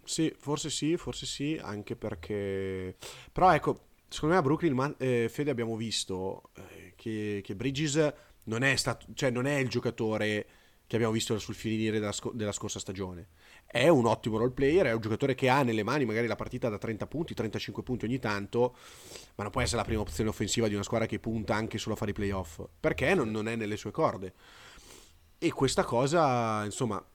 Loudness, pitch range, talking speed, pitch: -30 LUFS, 105-130 Hz, 200 wpm, 115 Hz